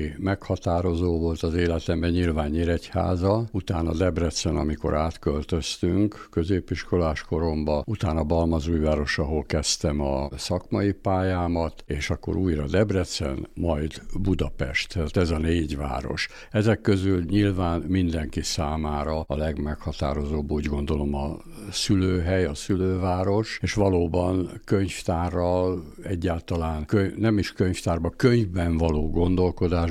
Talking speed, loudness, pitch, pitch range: 110 wpm, -25 LUFS, 85 Hz, 80-95 Hz